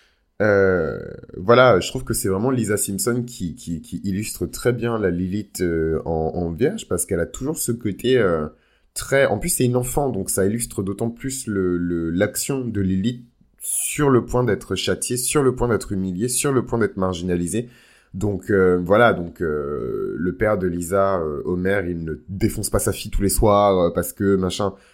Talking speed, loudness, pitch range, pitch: 195 wpm, -21 LUFS, 90-120 Hz, 100 Hz